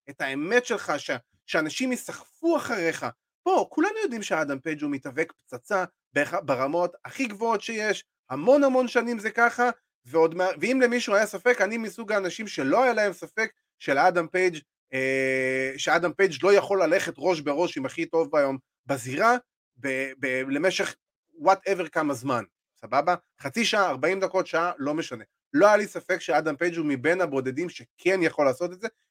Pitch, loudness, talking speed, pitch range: 180 Hz, -25 LUFS, 165 wpm, 150-225 Hz